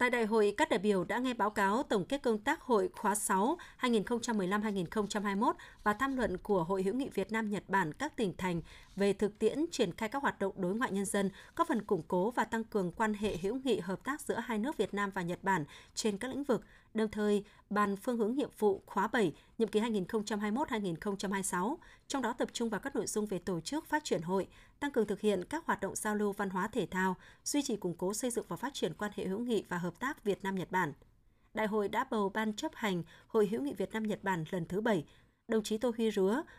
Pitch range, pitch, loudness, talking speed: 195-235 Hz, 210 Hz, -34 LUFS, 245 wpm